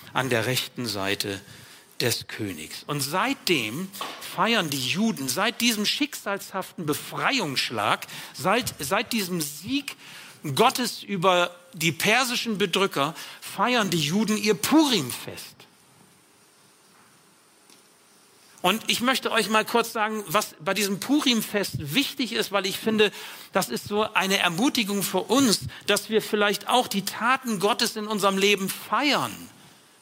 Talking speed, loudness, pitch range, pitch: 125 wpm, -24 LUFS, 175-225 Hz, 200 Hz